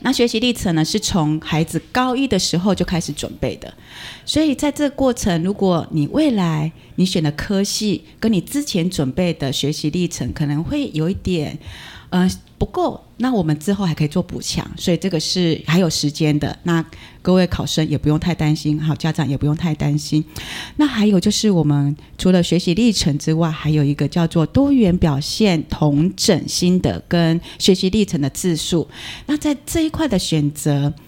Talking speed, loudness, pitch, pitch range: 280 characters per minute, -18 LUFS, 170 Hz, 150-195 Hz